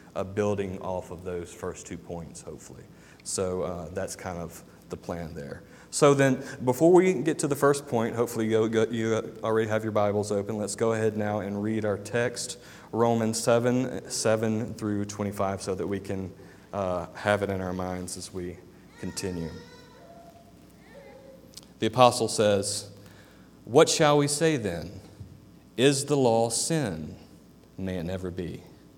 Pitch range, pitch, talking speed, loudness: 95-115 Hz, 105 Hz, 160 wpm, -27 LUFS